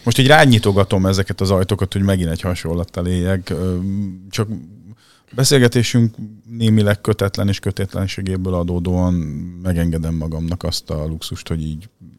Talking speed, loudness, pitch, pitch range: 125 wpm, -18 LUFS, 95 Hz, 90-110 Hz